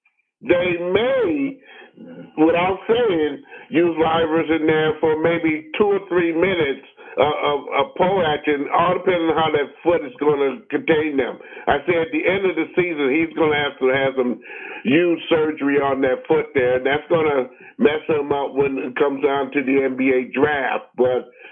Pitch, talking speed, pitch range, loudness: 160 Hz, 180 wpm, 140-175 Hz, -19 LUFS